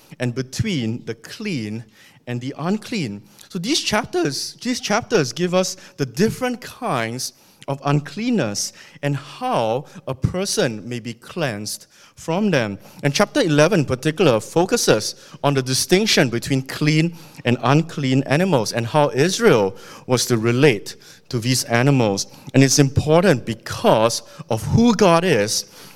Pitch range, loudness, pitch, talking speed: 120-180 Hz, -20 LUFS, 140 Hz, 140 wpm